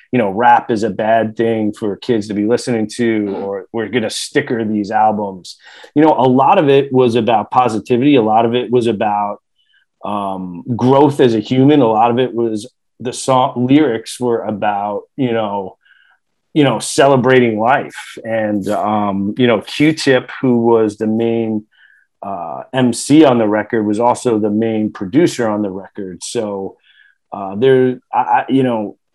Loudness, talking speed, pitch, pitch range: -14 LUFS, 175 wpm, 115 Hz, 105-125 Hz